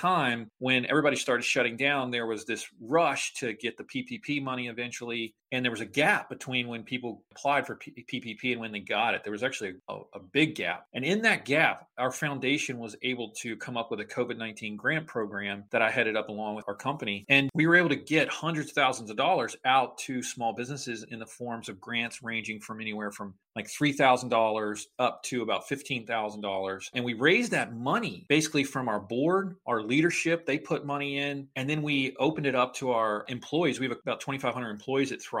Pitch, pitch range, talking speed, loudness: 125 Hz, 110-140 Hz, 210 wpm, -29 LUFS